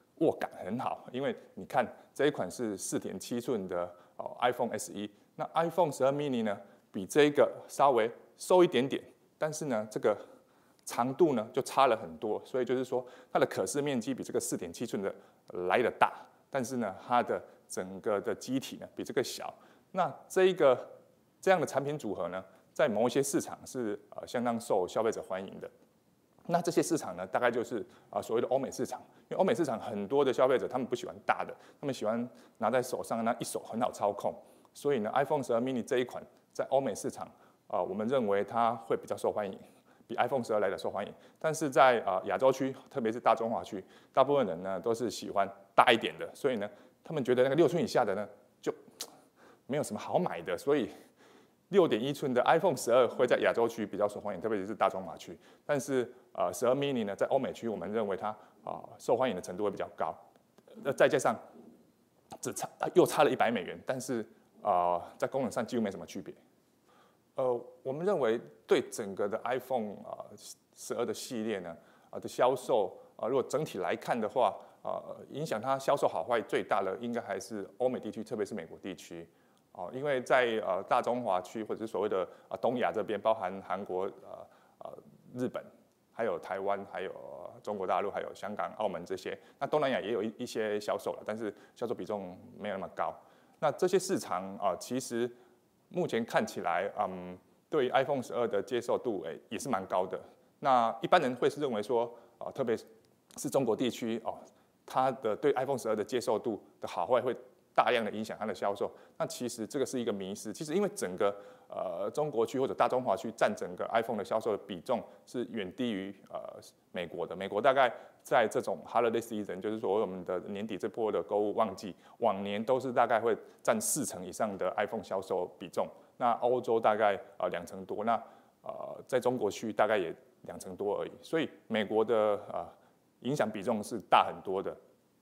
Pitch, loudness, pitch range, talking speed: 120 Hz, -32 LUFS, 105-145 Hz, 325 characters per minute